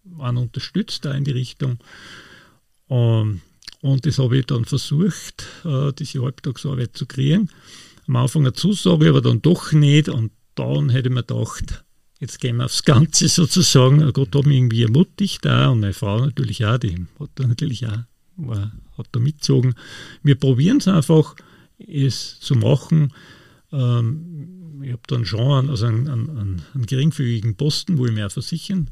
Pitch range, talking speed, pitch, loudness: 120-150 Hz, 160 wpm, 135 Hz, -19 LUFS